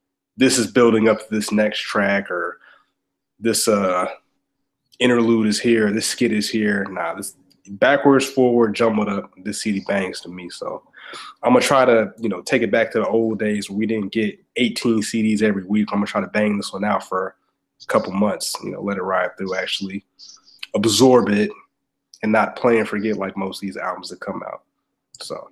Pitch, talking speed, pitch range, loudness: 110 Hz, 200 wpm, 100-115 Hz, -19 LUFS